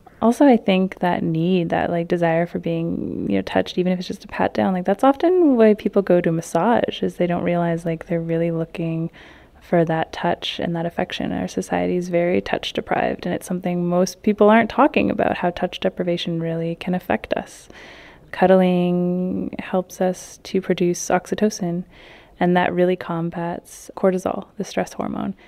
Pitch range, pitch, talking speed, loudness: 170-190 Hz, 180 Hz, 180 wpm, -20 LUFS